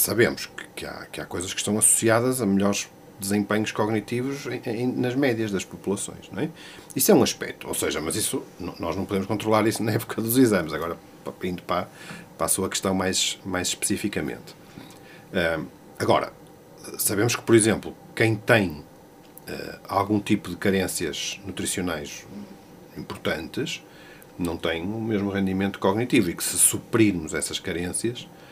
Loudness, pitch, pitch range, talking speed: -24 LUFS, 105 Hz, 95-115 Hz, 150 wpm